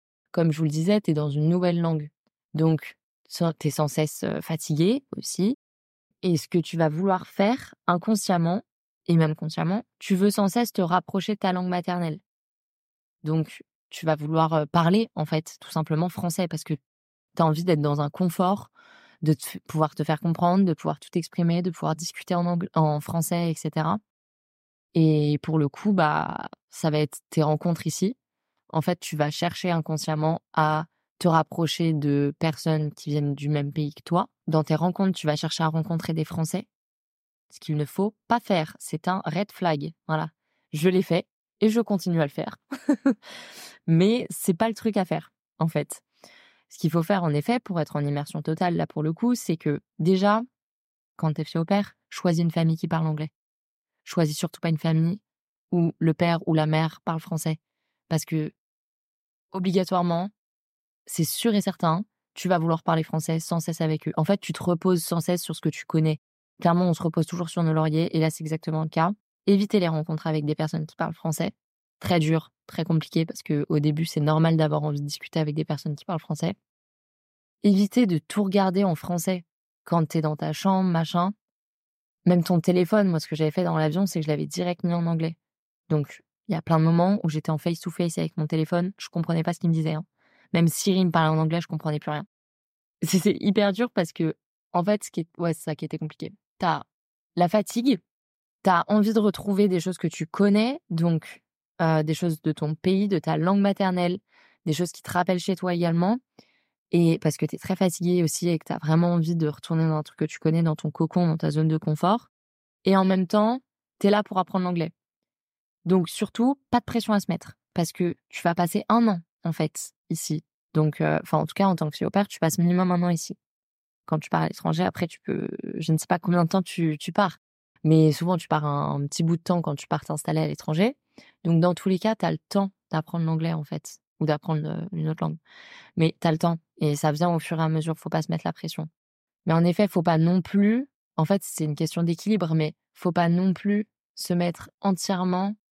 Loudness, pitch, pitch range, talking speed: -25 LUFS, 170 Hz, 160-185 Hz, 220 wpm